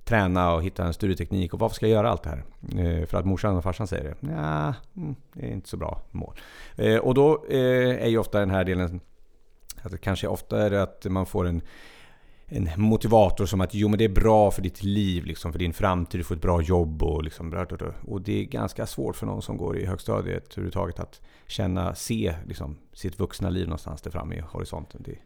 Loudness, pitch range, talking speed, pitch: -26 LUFS, 85-105 Hz, 225 wpm, 95 Hz